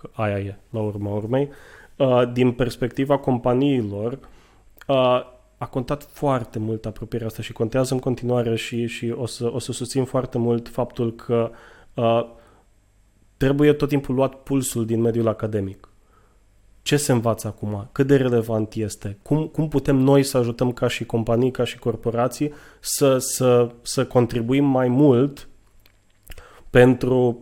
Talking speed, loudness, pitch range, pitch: 140 wpm, -22 LUFS, 115-130 Hz, 120 Hz